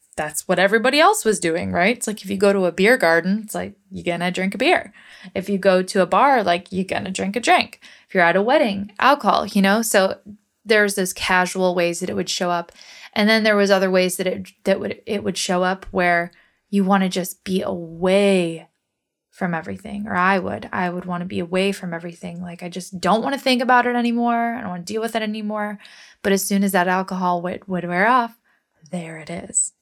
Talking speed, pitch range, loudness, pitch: 235 wpm, 180-210 Hz, -19 LUFS, 190 Hz